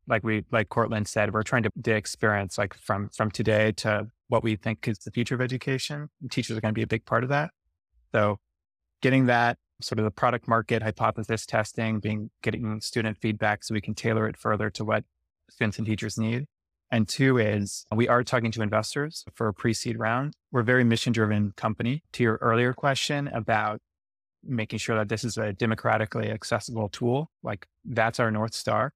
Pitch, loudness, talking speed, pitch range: 110 Hz, -27 LUFS, 195 wpm, 110-120 Hz